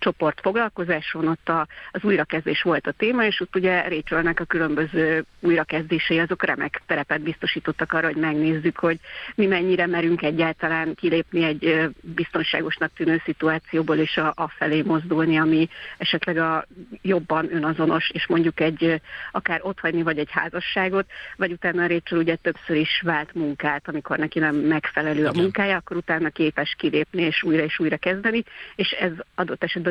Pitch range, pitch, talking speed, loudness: 160-175 Hz, 165 Hz, 155 wpm, -23 LUFS